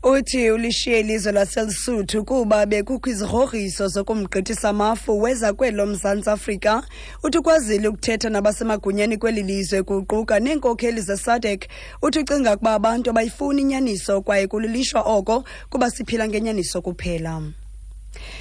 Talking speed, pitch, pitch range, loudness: 115 wpm, 220 Hz, 205-240 Hz, -21 LUFS